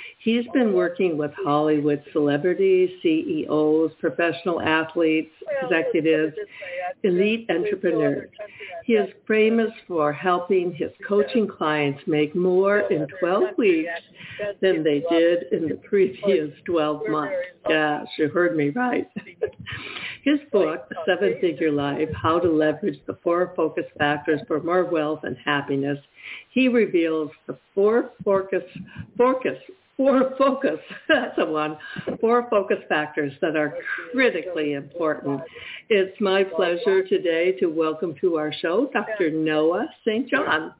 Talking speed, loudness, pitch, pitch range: 125 wpm, -23 LUFS, 180 Hz, 155-220 Hz